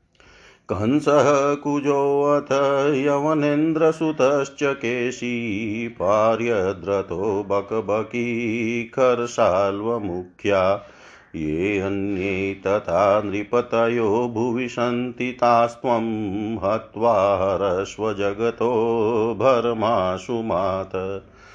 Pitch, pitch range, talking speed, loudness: 115 Hz, 100-125 Hz, 45 wpm, -21 LUFS